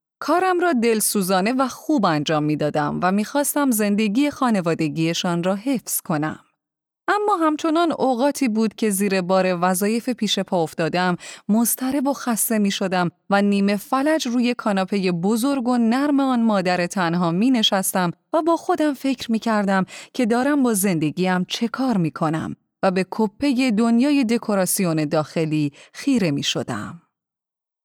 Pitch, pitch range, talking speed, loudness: 215 Hz, 185-260 Hz, 145 wpm, -20 LUFS